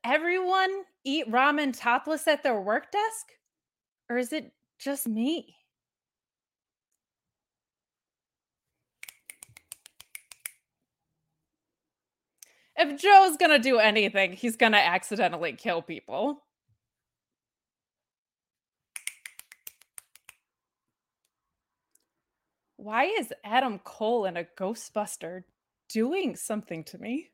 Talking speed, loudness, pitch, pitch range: 75 wpm, -26 LUFS, 250 Hz, 210-310 Hz